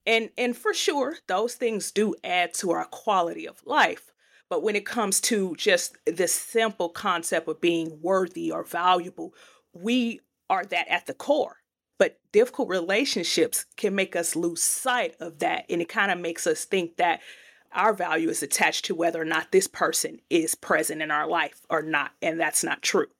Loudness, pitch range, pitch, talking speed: -25 LUFS, 175-250 Hz, 205 Hz, 185 wpm